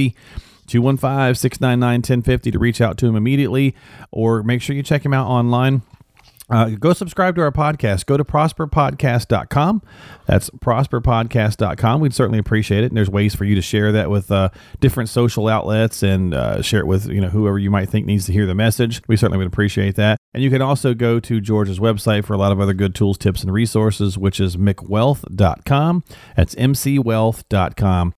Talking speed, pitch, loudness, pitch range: 190 wpm, 115 Hz, -17 LUFS, 105-130 Hz